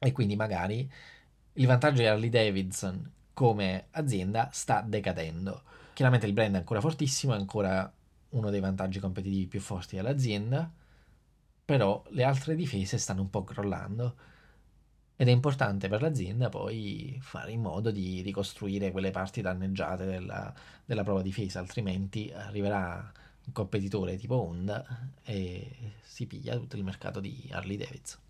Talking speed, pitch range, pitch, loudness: 145 wpm, 95-125 Hz, 105 Hz, -31 LUFS